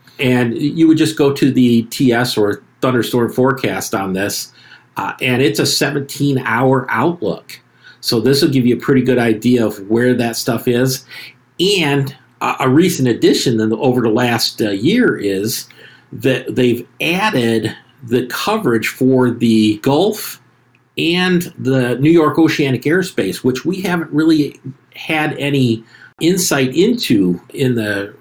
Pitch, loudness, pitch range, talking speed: 125 Hz, -15 LUFS, 115-140 Hz, 150 wpm